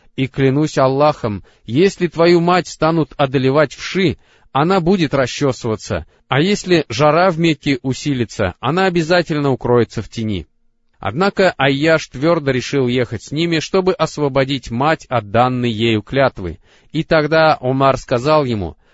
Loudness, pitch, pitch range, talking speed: -16 LUFS, 140 Hz, 120-160 Hz, 135 wpm